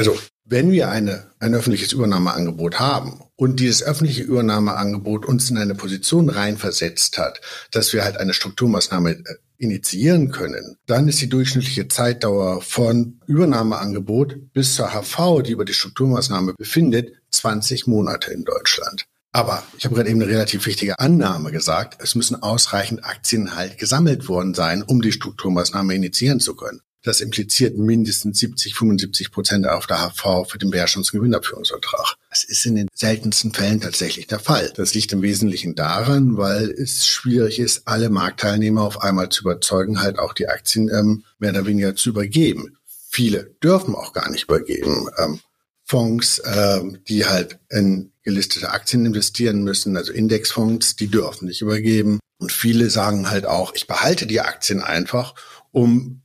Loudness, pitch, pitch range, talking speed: -19 LUFS, 110 Hz, 100-120 Hz, 155 wpm